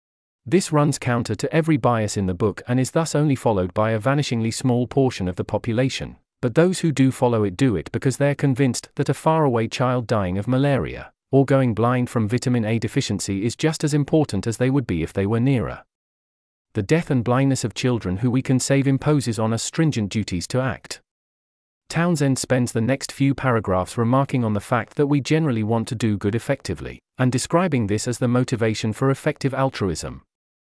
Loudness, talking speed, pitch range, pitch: -21 LUFS, 200 wpm, 110-140 Hz, 125 Hz